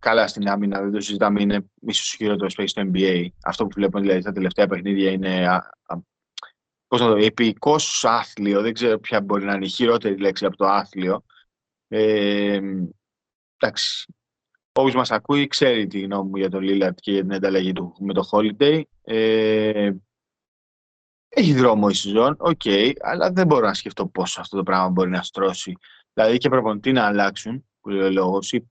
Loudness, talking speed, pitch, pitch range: -21 LUFS, 180 wpm, 100 Hz, 95-110 Hz